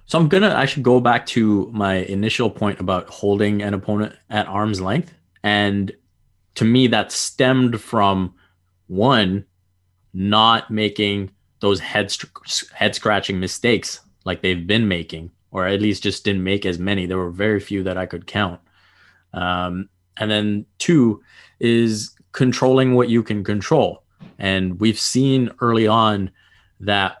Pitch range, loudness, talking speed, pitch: 95-110 Hz, -19 LUFS, 150 wpm, 105 Hz